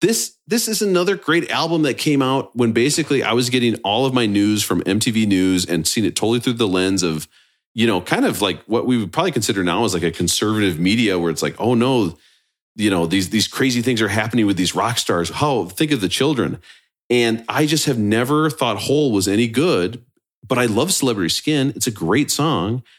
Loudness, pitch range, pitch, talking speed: -18 LUFS, 100-135 Hz, 115 Hz, 225 wpm